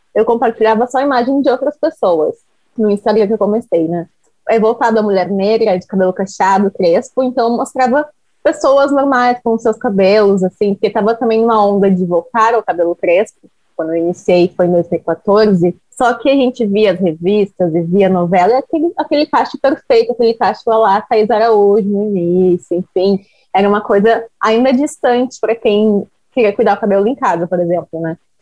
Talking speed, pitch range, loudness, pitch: 175 wpm, 190-245 Hz, -13 LUFS, 215 Hz